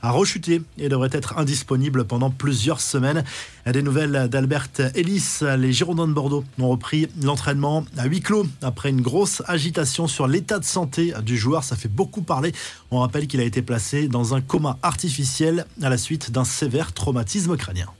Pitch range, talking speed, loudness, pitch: 130-160 Hz, 180 wpm, -22 LUFS, 140 Hz